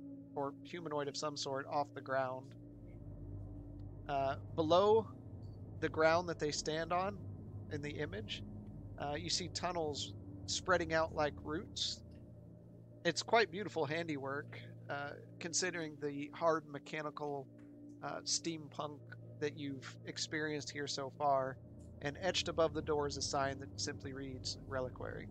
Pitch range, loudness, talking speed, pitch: 105-150 Hz, -39 LUFS, 135 wpm, 140 Hz